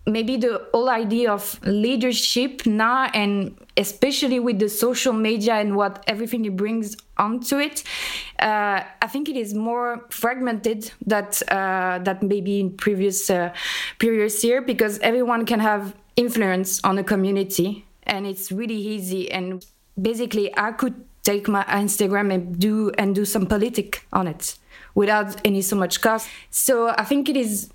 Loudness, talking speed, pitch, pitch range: -22 LUFS, 160 wpm, 215 Hz, 200-235 Hz